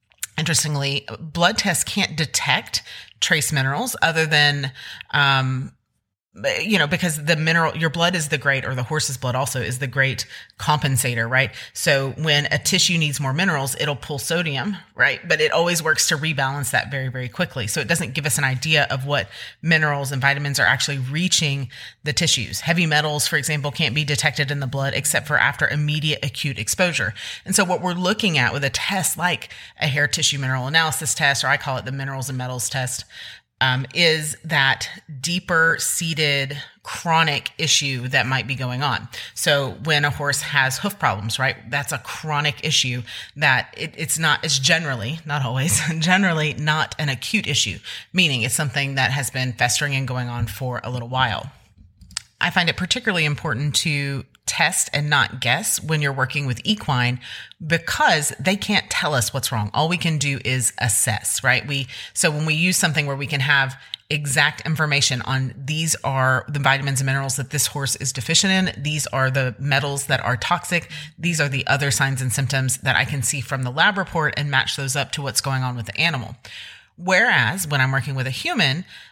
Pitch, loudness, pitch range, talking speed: 145 Hz, -20 LUFS, 130-160 Hz, 195 wpm